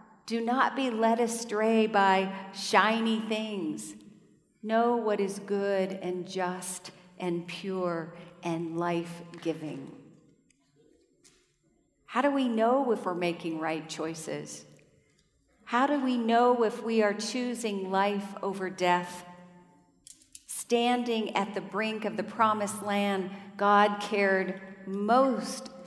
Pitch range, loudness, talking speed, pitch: 180-225 Hz, -29 LUFS, 115 wpm, 200 Hz